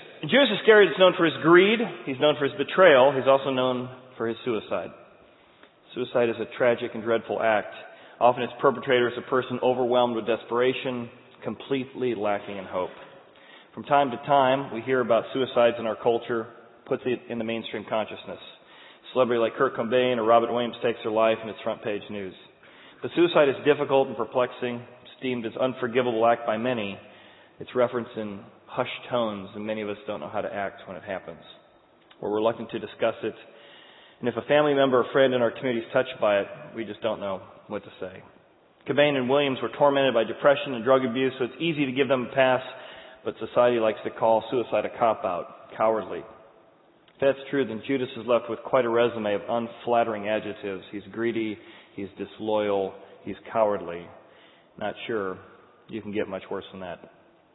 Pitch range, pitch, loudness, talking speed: 115-130 Hz, 120 Hz, -25 LUFS, 195 wpm